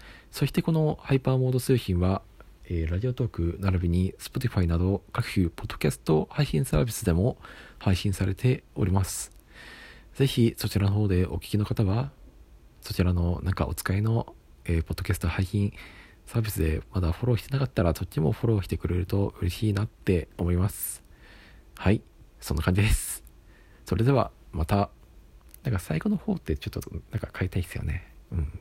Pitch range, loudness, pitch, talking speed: 85-115 Hz, -28 LUFS, 95 Hz, 380 characters per minute